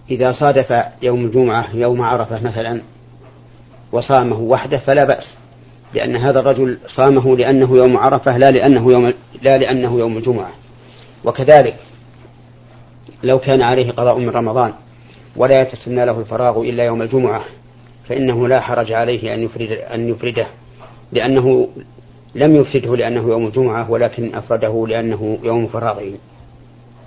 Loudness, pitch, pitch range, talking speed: -15 LUFS, 120 Hz, 115-130 Hz, 130 wpm